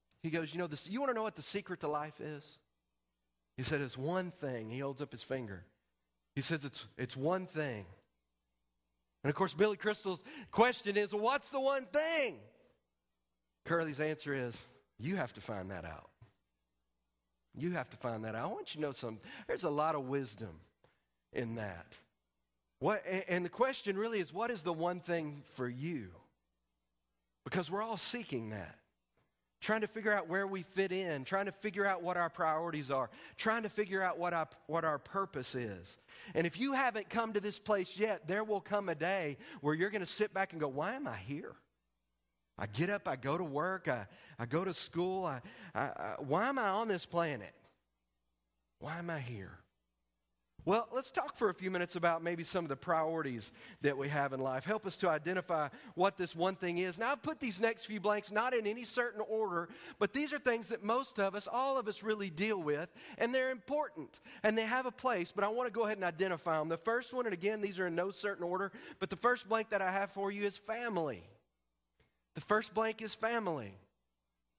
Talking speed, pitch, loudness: 210 wpm, 170 Hz, -37 LUFS